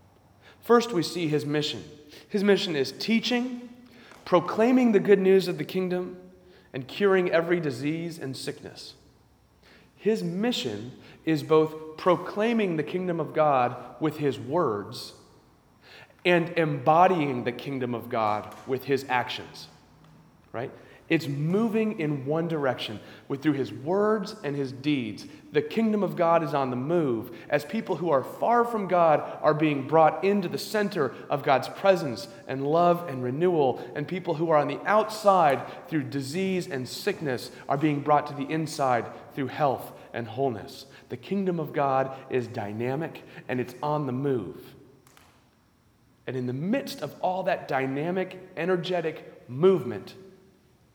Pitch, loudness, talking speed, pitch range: 155 Hz, -26 LUFS, 150 wpm, 135-185 Hz